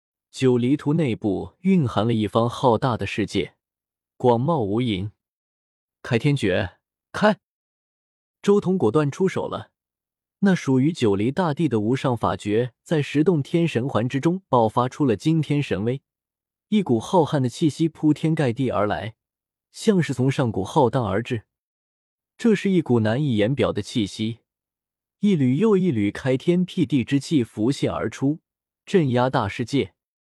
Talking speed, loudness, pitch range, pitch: 220 characters per minute, -22 LUFS, 115-160 Hz, 135 Hz